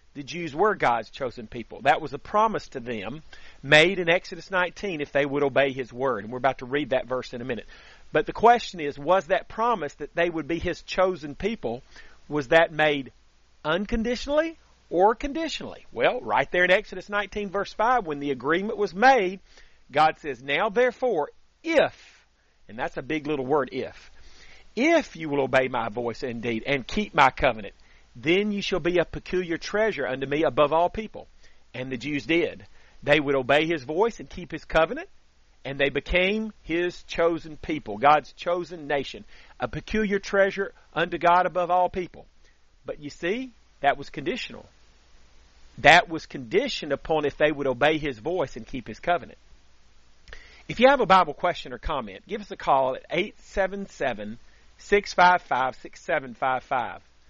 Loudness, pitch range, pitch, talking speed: -25 LUFS, 140-195 Hz, 160 Hz, 170 wpm